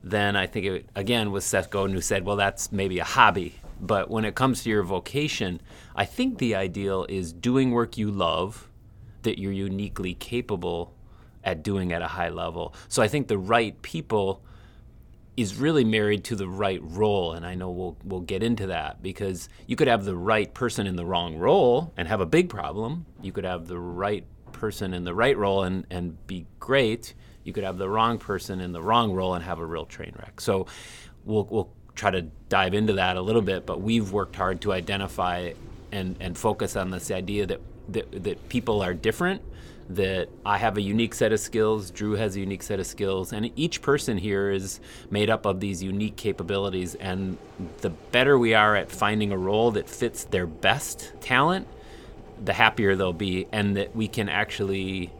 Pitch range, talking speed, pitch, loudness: 95-110 Hz, 200 wpm, 100 Hz, -26 LUFS